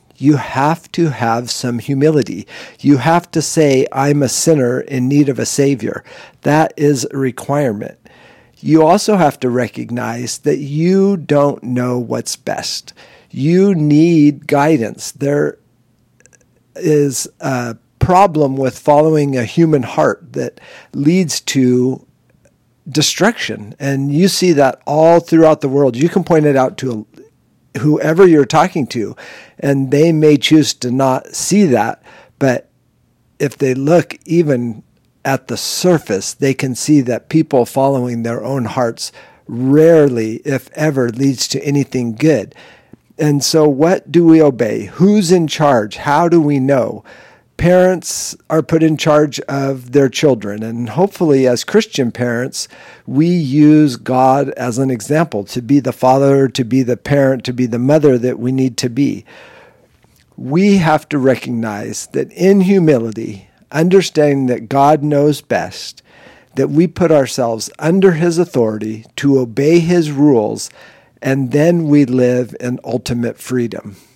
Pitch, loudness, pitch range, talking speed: 140 Hz, -14 LUFS, 125-160 Hz, 145 wpm